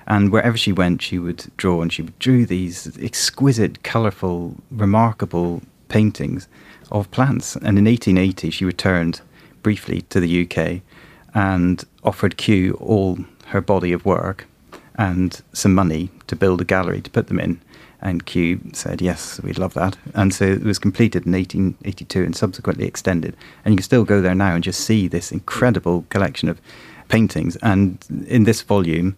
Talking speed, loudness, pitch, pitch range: 165 wpm, -19 LUFS, 95 Hz, 90-105 Hz